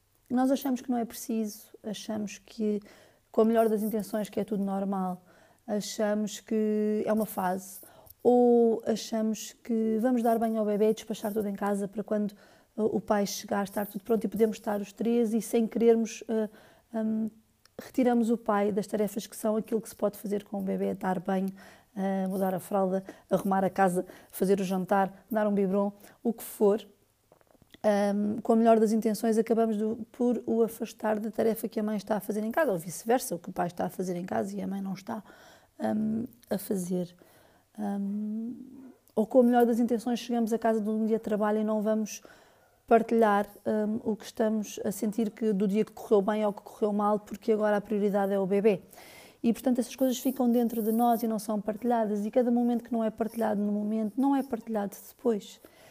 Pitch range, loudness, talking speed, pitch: 205-230 Hz, -29 LUFS, 205 wpm, 215 Hz